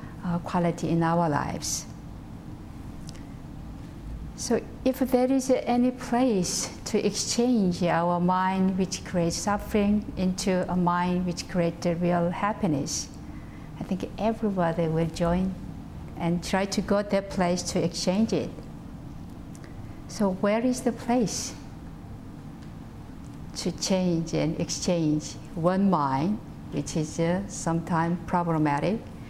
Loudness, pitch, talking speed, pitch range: -26 LUFS, 180 Hz, 115 wpm, 170-205 Hz